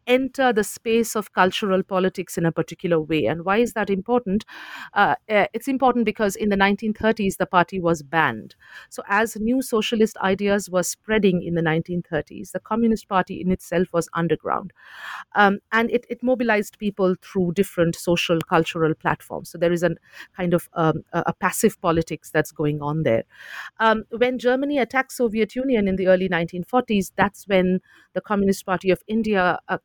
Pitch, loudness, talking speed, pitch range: 190 Hz, -22 LUFS, 175 wpm, 170-220 Hz